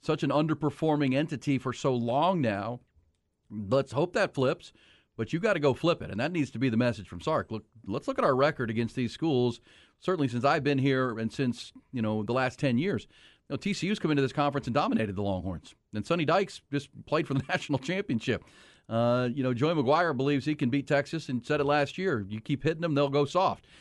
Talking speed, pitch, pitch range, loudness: 230 wpm, 135 Hz, 115-150 Hz, -29 LUFS